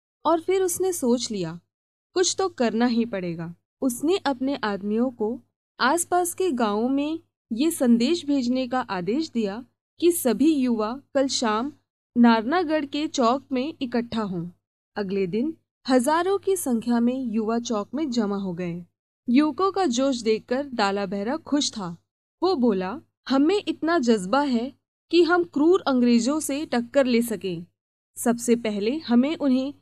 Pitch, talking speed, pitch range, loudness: 255 Hz, 145 wpm, 225-305 Hz, -24 LUFS